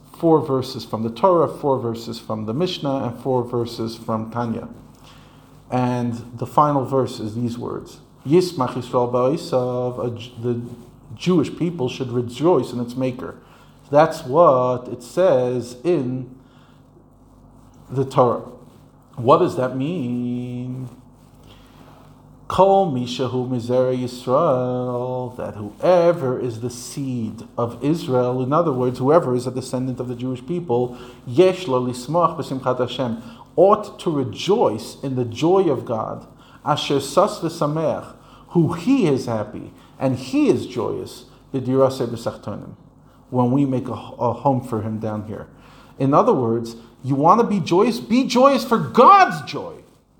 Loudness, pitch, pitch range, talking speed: -20 LUFS, 125 Hz, 125-140 Hz, 120 wpm